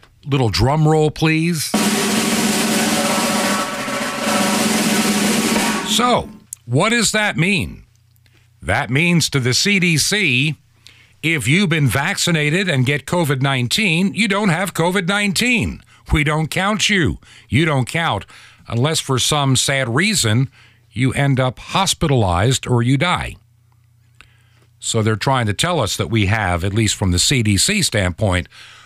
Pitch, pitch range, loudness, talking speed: 145 Hz, 115-190 Hz, -16 LUFS, 125 wpm